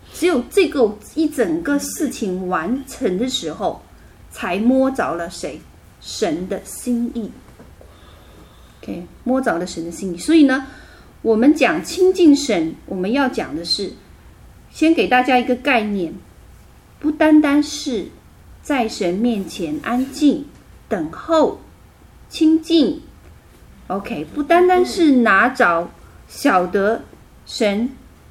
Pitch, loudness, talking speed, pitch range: 250 Hz, -18 LUFS, 175 characters per minute, 195-300 Hz